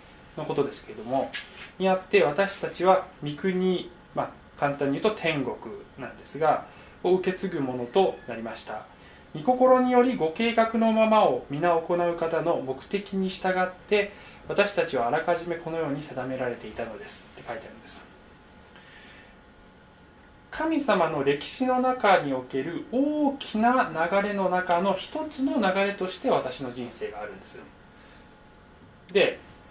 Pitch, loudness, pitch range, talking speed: 185 Hz, -26 LUFS, 150-220 Hz, 285 characters per minute